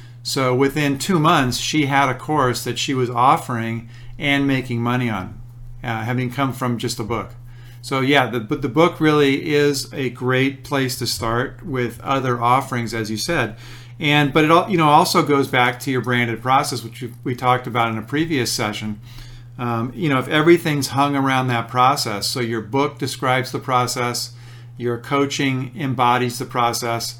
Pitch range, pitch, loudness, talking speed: 120-140 Hz, 125 Hz, -19 LUFS, 180 wpm